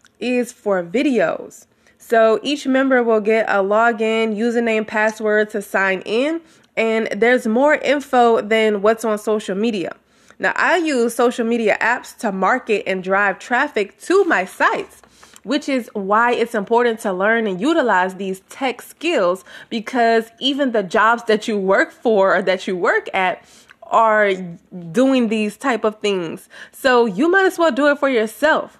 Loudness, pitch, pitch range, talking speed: -18 LUFS, 225 Hz, 210-255 Hz, 165 wpm